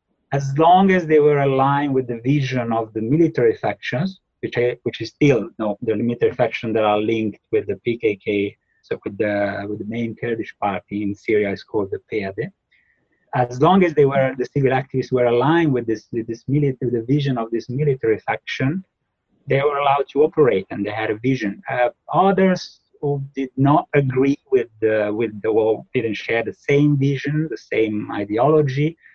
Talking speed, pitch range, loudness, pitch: 190 wpm, 115-150 Hz, -20 LUFS, 135 Hz